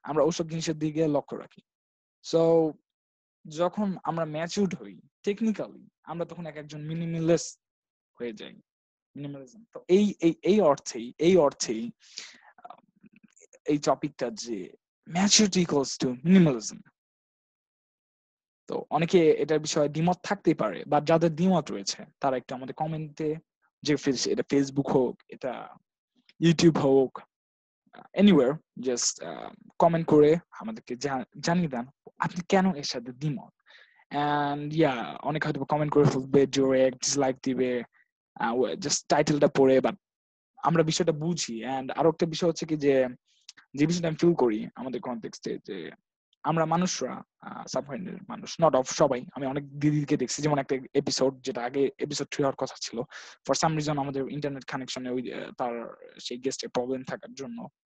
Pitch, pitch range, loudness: 150 Hz, 135-170 Hz, -27 LUFS